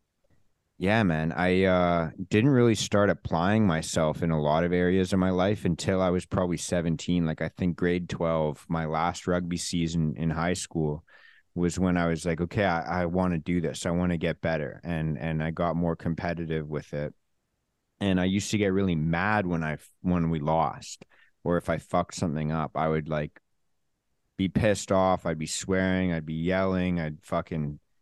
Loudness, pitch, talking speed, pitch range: -27 LUFS, 85 Hz, 195 wpm, 80-95 Hz